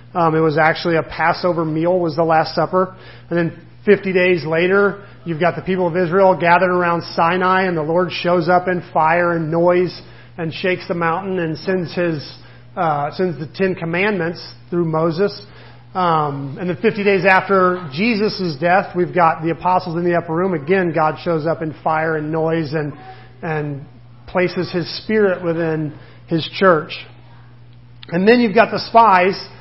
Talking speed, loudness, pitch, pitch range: 175 wpm, -17 LUFS, 170 Hz, 160-185 Hz